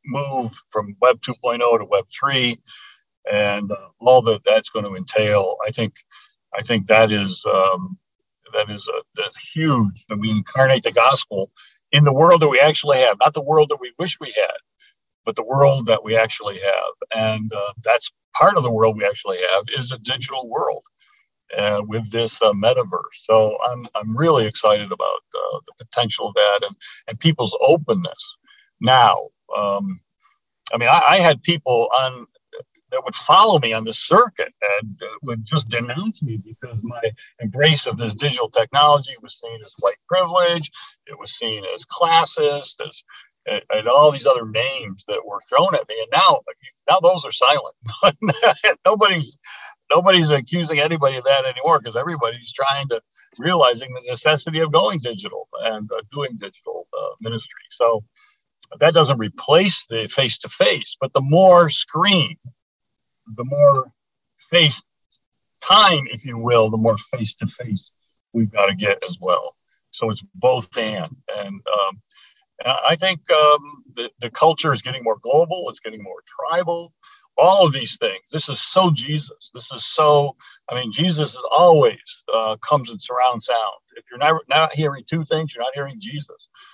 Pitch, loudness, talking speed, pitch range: 140 Hz, -18 LUFS, 170 wpm, 115-165 Hz